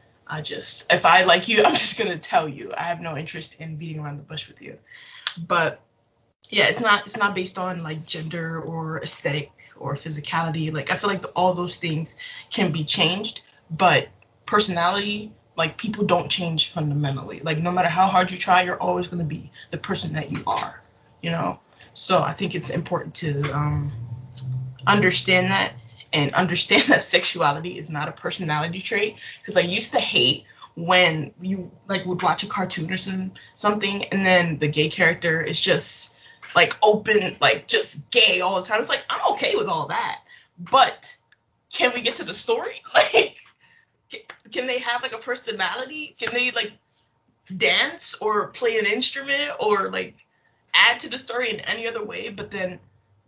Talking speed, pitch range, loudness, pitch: 180 wpm, 155-210 Hz, -21 LUFS, 180 Hz